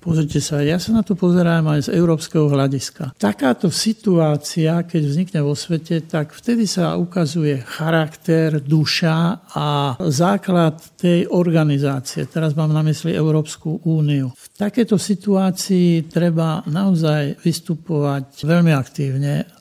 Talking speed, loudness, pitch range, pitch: 125 wpm, -18 LUFS, 150-175 Hz, 160 Hz